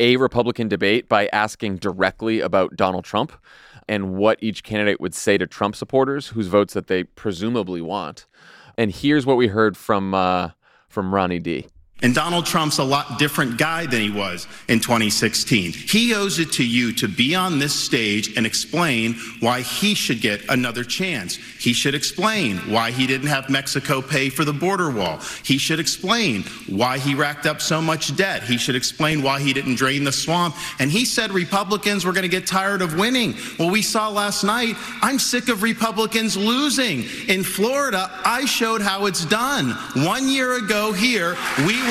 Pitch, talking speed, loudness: 140 Hz, 185 wpm, -20 LUFS